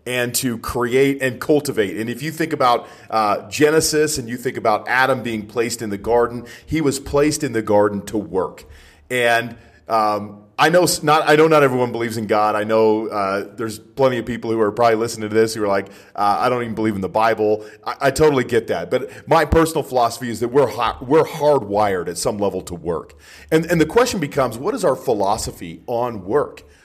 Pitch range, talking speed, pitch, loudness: 105-140 Hz, 215 wpm, 120 Hz, -19 LUFS